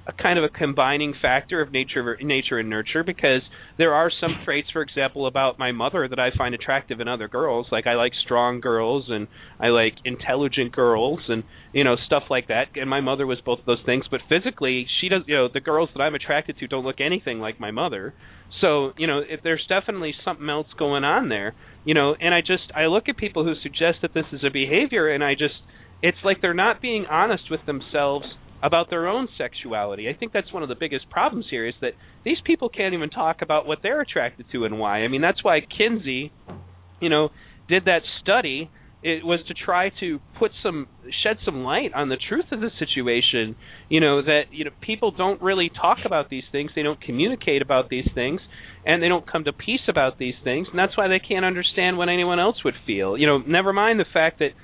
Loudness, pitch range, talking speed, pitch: -22 LUFS, 130-175 Hz, 225 wpm, 150 Hz